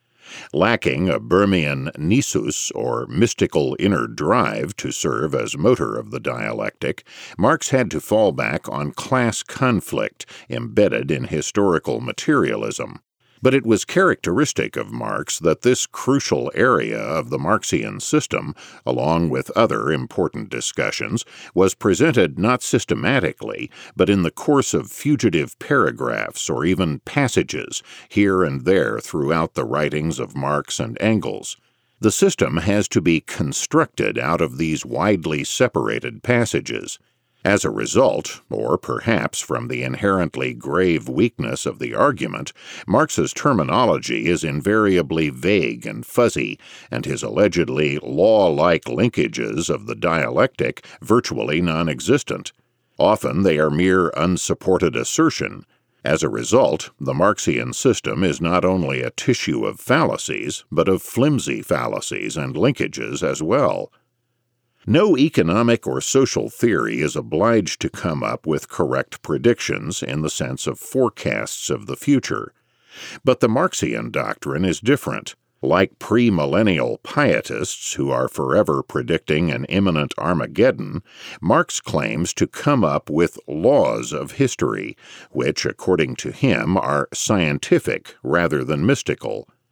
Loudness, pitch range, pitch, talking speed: -20 LUFS, 80-120 Hz, 95 Hz, 130 wpm